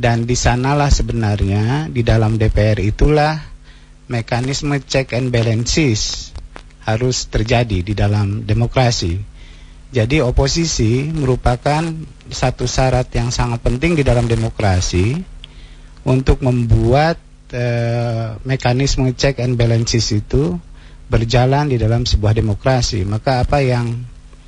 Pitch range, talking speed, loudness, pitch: 110-130 Hz, 110 wpm, -17 LUFS, 120 Hz